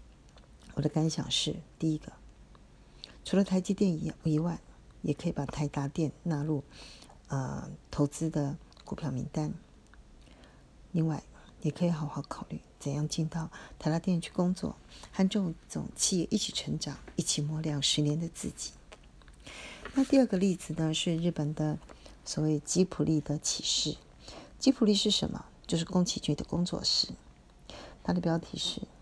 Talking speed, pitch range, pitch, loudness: 225 characters per minute, 150-180 Hz, 160 Hz, -31 LUFS